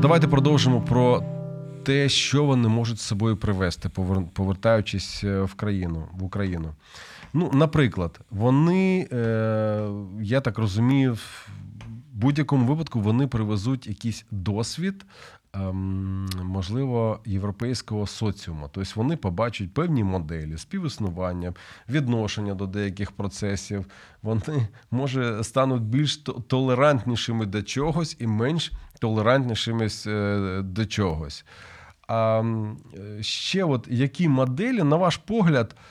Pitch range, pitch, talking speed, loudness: 100-135 Hz, 115 Hz, 100 wpm, -25 LUFS